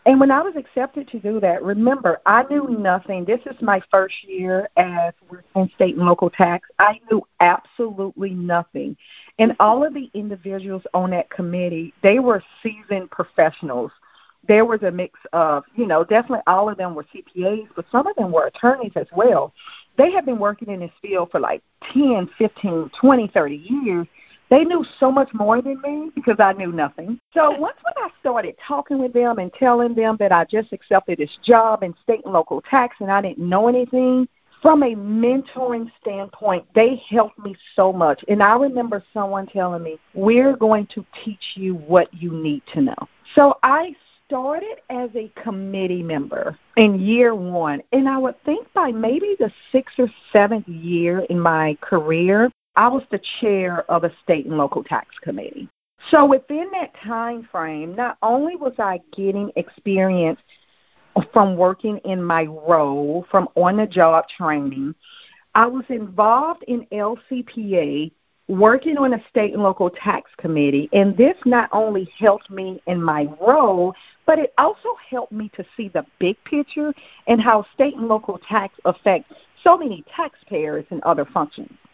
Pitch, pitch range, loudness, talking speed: 210 Hz, 180-250 Hz, -19 LUFS, 175 wpm